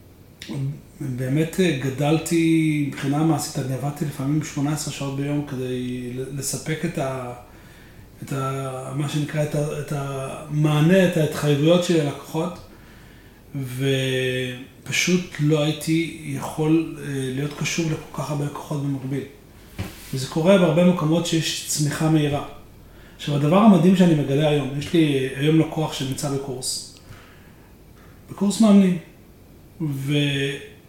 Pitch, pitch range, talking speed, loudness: 145 Hz, 135-155 Hz, 115 wpm, -22 LUFS